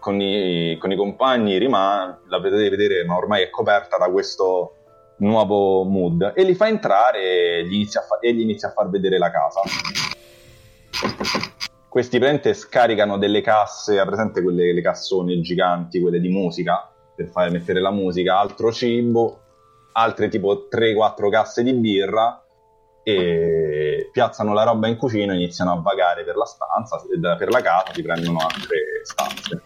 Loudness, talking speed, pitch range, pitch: -20 LUFS, 160 wpm, 90-115 Hz, 100 Hz